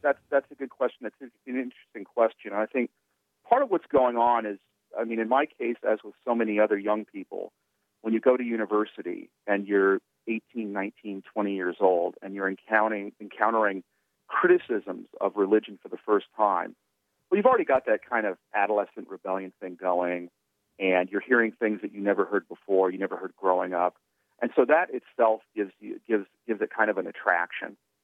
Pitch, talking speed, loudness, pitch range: 105 Hz, 195 wpm, -27 LUFS, 100-115 Hz